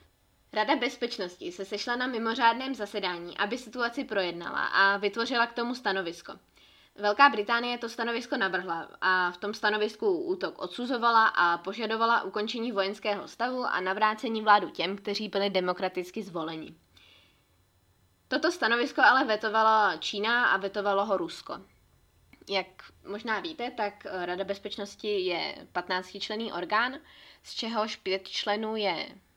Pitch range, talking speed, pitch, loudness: 190-235 Hz, 130 wpm, 210 Hz, -28 LUFS